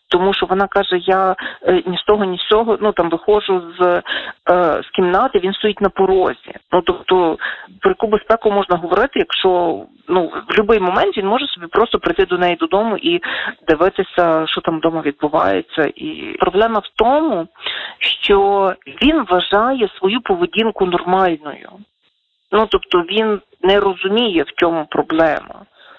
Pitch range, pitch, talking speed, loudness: 180-215 Hz, 190 Hz, 150 wpm, -16 LUFS